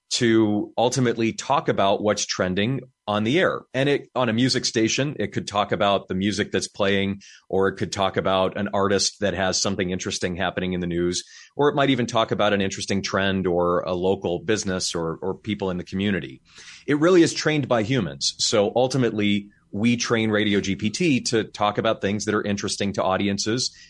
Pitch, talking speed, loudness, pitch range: 105 Hz, 195 wpm, -23 LUFS, 95-115 Hz